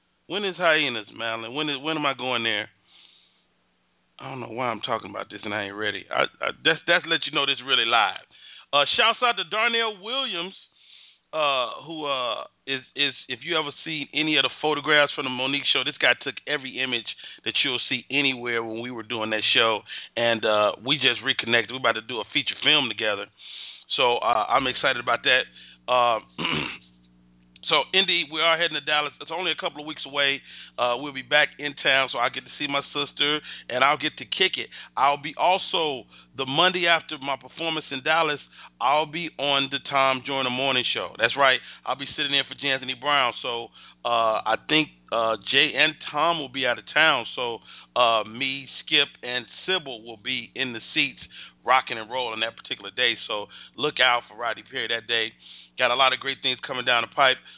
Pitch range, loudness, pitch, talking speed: 120-150 Hz, -23 LUFS, 135 Hz, 210 wpm